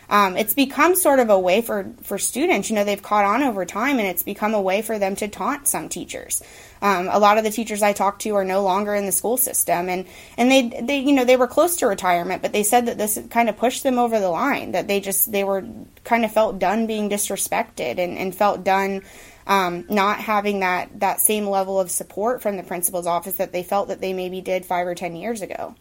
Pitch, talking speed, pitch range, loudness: 205 Hz, 250 wpm, 190-230 Hz, -20 LUFS